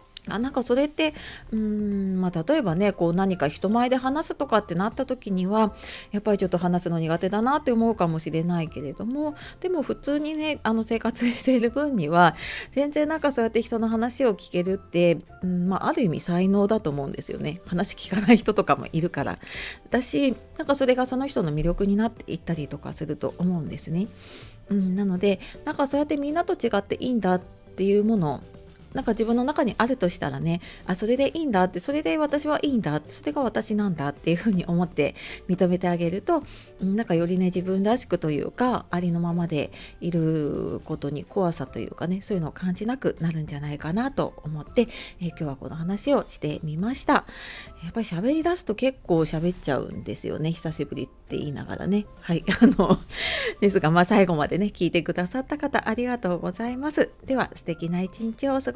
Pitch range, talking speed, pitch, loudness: 170-245 Hz, 410 characters per minute, 195 Hz, -25 LUFS